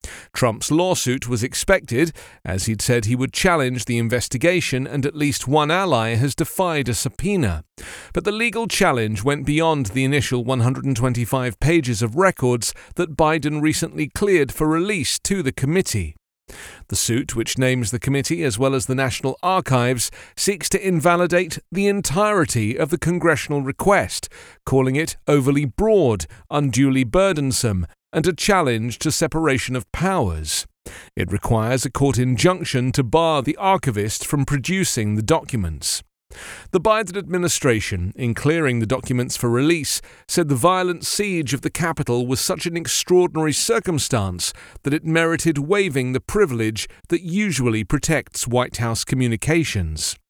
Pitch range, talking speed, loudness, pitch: 125-170 Hz, 145 wpm, -20 LUFS, 140 Hz